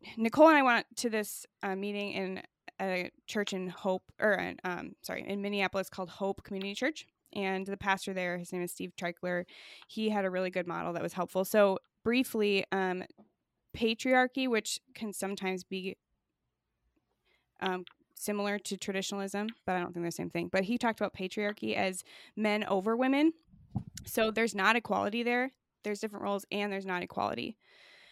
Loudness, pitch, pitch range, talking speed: -32 LUFS, 200 Hz, 185-220 Hz, 175 wpm